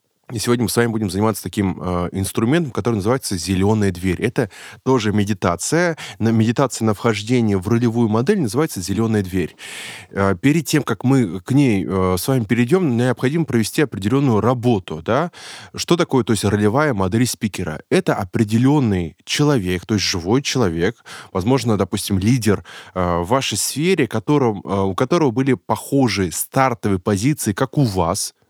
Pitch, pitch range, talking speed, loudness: 115 Hz, 100-130 Hz, 145 wpm, -19 LUFS